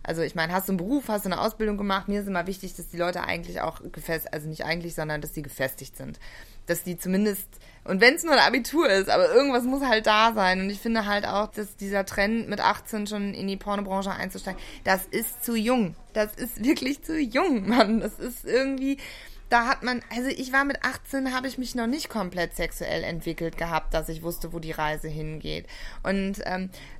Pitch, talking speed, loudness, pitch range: 200 Hz, 220 wpm, -26 LUFS, 170-240 Hz